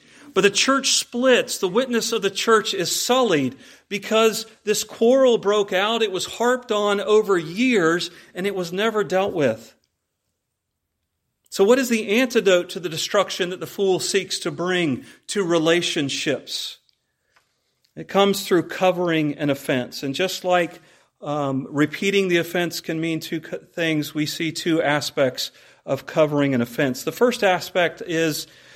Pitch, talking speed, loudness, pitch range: 180 Hz, 155 wpm, -21 LUFS, 160-210 Hz